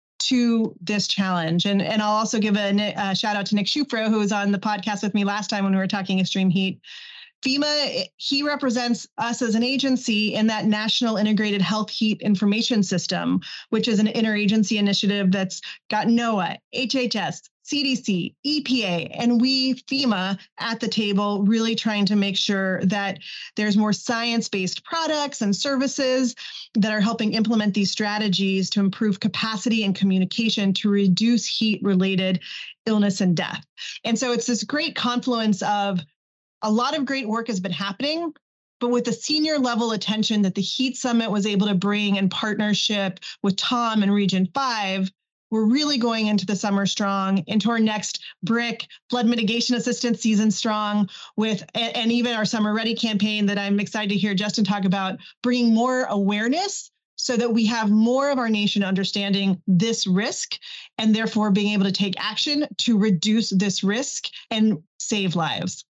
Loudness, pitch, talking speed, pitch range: -22 LUFS, 215 Hz, 170 wpm, 200-235 Hz